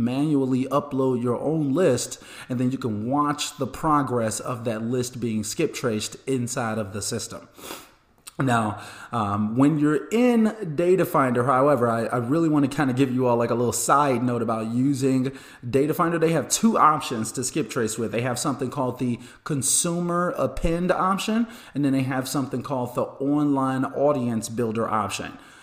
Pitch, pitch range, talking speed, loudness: 130 Hz, 120-150 Hz, 180 wpm, -23 LUFS